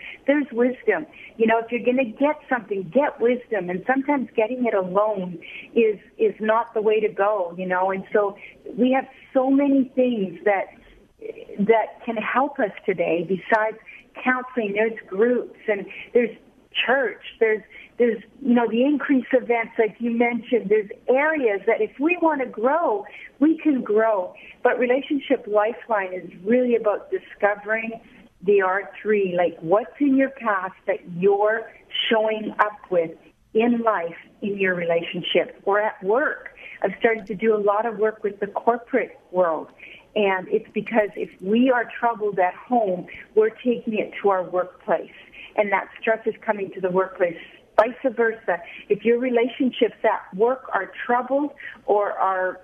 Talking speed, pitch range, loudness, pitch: 160 wpm, 205-245 Hz, -23 LUFS, 225 Hz